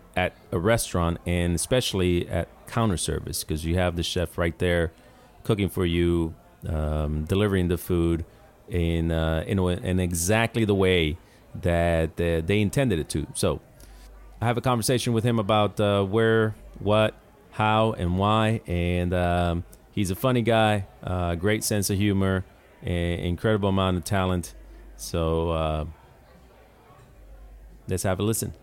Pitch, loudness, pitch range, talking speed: 90 Hz, -25 LUFS, 85-105 Hz, 150 wpm